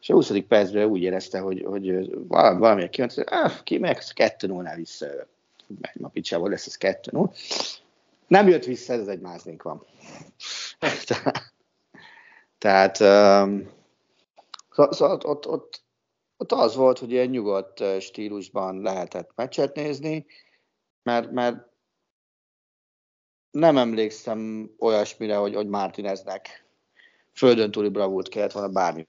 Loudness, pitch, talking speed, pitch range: -23 LUFS, 105 Hz, 125 wpm, 95-120 Hz